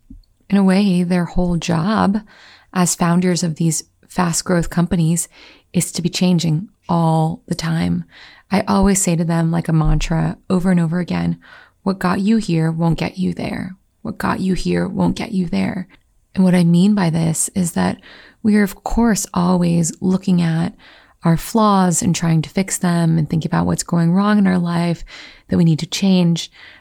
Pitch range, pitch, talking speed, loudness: 165-190 Hz, 175 Hz, 190 wpm, -17 LUFS